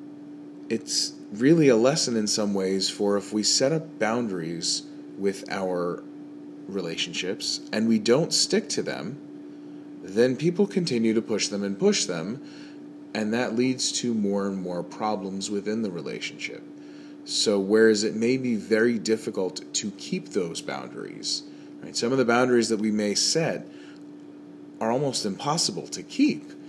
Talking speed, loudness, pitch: 150 wpm, -25 LUFS, 120 Hz